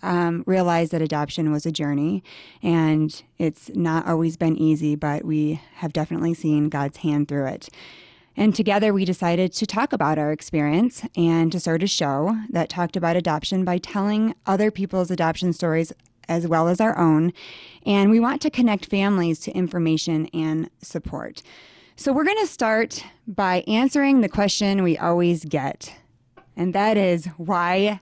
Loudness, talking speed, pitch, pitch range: -22 LUFS, 165 wpm, 170 Hz, 160-200 Hz